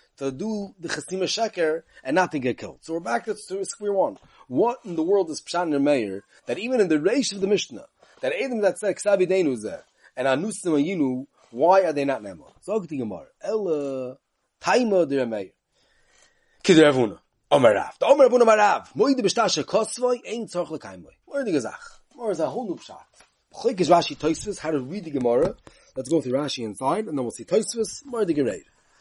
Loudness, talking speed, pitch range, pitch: -23 LUFS, 205 wpm, 150-220 Hz, 185 Hz